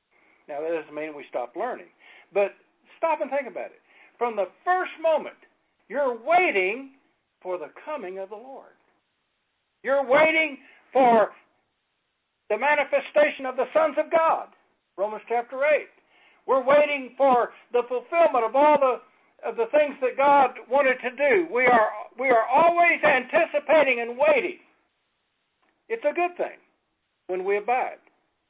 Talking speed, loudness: 145 wpm, -23 LUFS